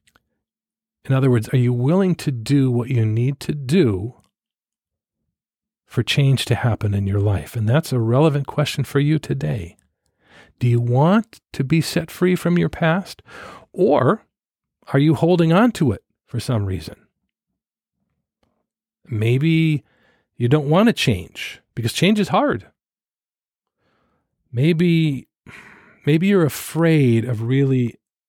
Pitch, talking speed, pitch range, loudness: 135 Hz, 135 wpm, 120-165 Hz, -19 LUFS